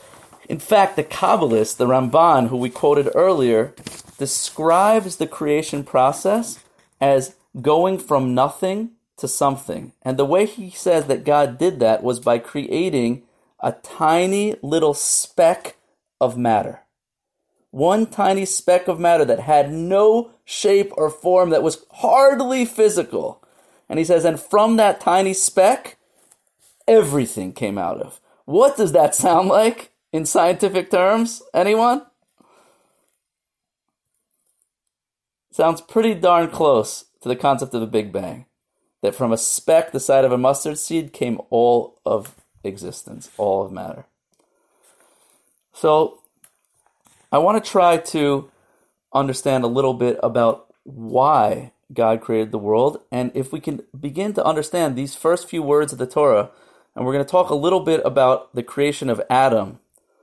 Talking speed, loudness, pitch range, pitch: 145 wpm, -18 LUFS, 130-190 Hz, 155 Hz